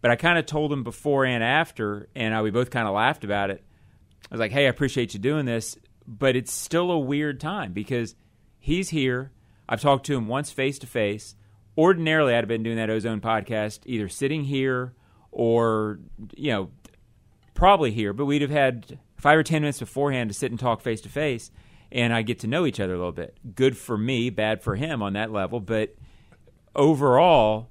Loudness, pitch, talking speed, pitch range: -24 LUFS, 120 Hz, 210 wpm, 110-140 Hz